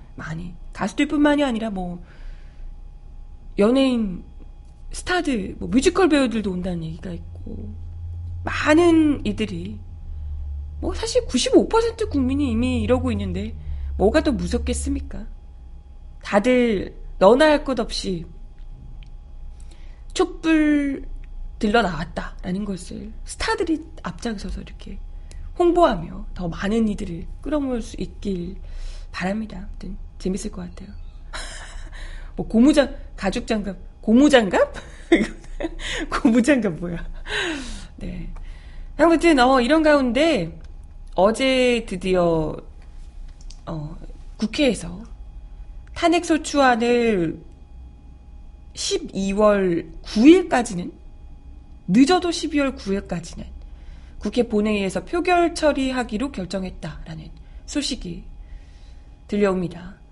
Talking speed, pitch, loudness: 205 characters per minute, 190 Hz, -21 LUFS